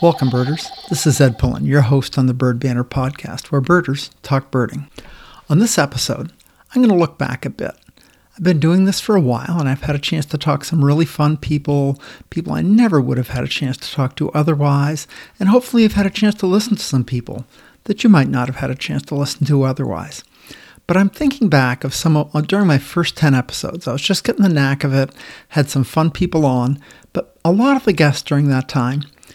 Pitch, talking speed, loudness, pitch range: 145 Hz, 230 wpm, -17 LUFS, 135-175 Hz